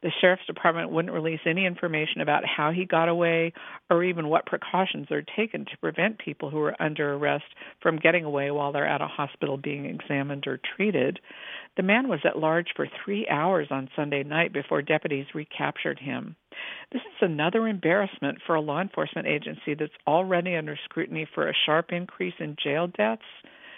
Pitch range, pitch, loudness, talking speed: 150-180 Hz, 165 Hz, -27 LUFS, 180 wpm